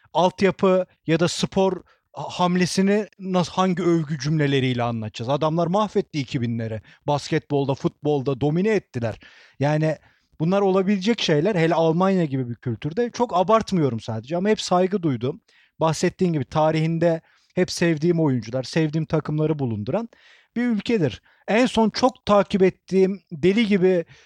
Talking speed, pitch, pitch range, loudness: 125 wpm, 170 Hz, 150-195 Hz, -22 LUFS